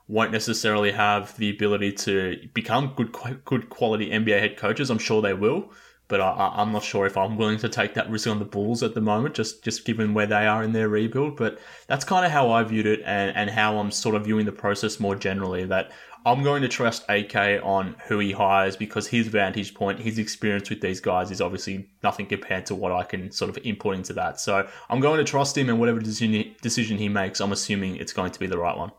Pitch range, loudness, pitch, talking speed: 100-115 Hz, -24 LUFS, 105 Hz, 240 wpm